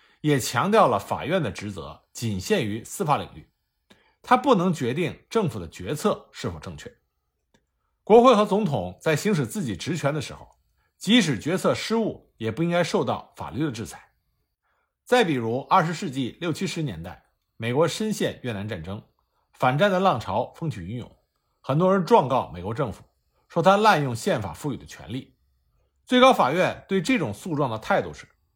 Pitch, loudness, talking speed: 150 Hz, -23 LUFS, 260 characters per minute